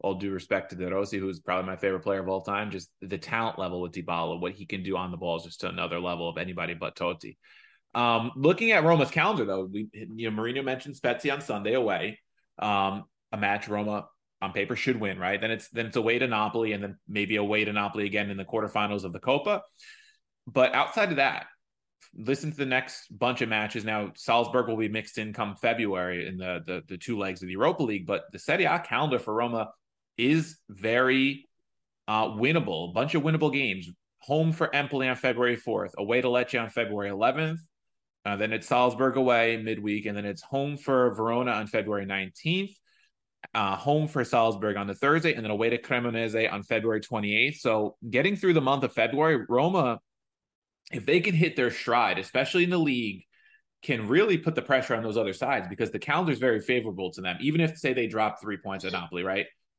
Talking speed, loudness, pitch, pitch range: 215 wpm, -27 LUFS, 110 Hz, 100-130 Hz